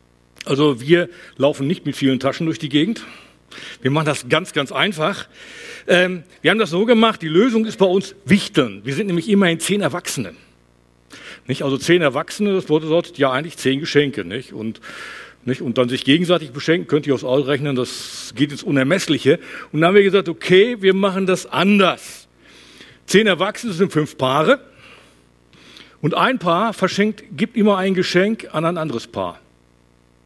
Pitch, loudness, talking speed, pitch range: 160 Hz, -18 LUFS, 175 wpm, 135-190 Hz